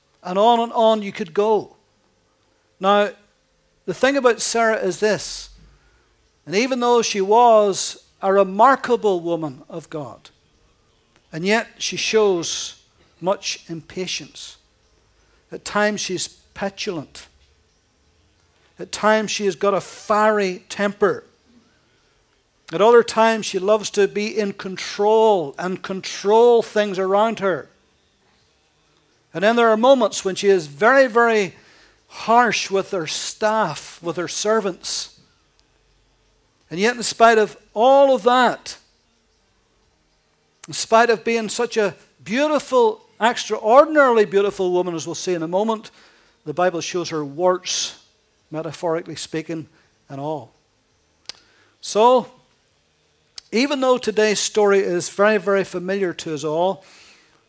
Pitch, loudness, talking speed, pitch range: 200 Hz, -19 LUFS, 125 wpm, 170-220 Hz